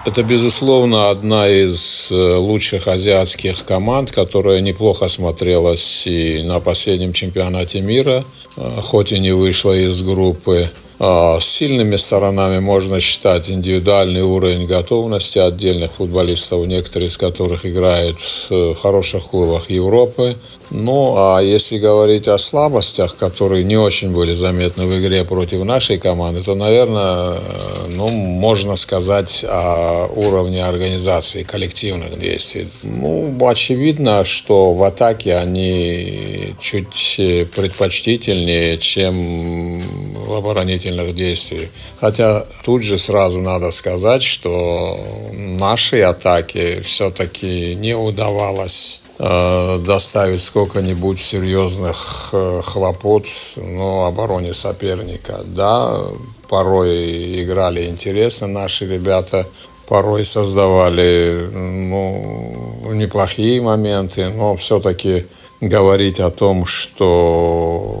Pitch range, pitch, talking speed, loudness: 90-105 Hz, 95 Hz, 100 wpm, -14 LUFS